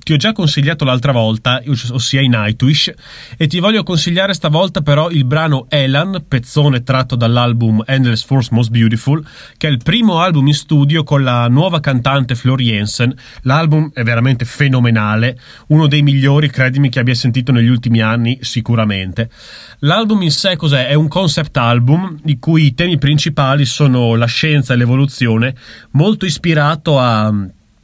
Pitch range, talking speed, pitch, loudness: 120-155 Hz, 160 wpm, 135 Hz, -13 LUFS